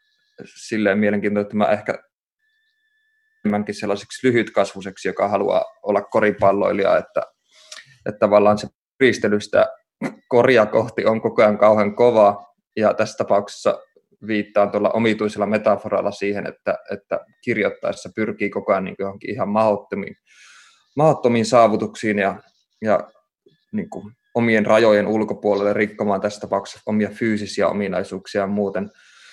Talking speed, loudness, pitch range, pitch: 110 wpm, -20 LUFS, 100-115 Hz, 105 Hz